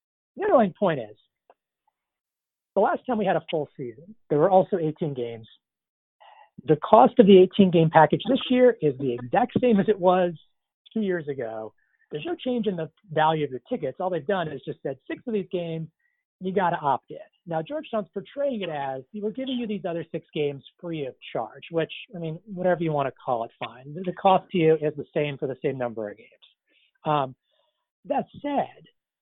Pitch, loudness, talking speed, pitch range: 175 Hz, -24 LUFS, 205 wpm, 150-215 Hz